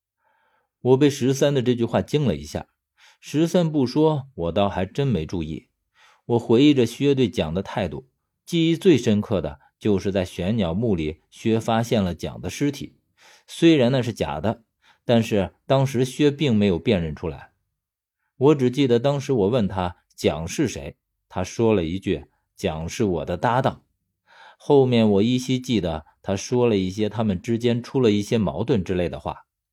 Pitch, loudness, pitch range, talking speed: 115 Hz, -22 LUFS, 95-135 Hz, 245 characters per minute